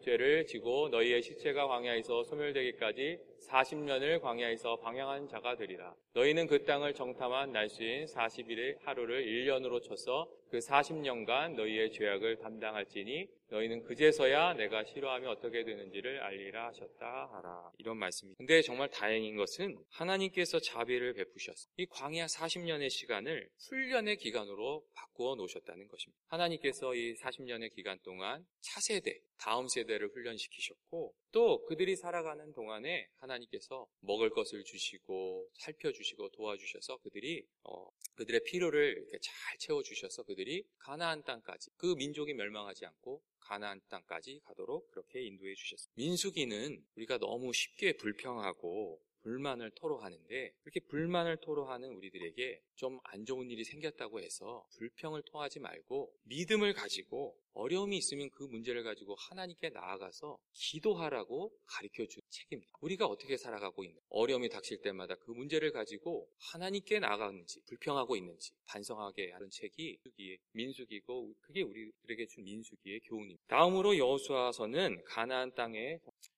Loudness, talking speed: -37 LUFS, 355 characters per minute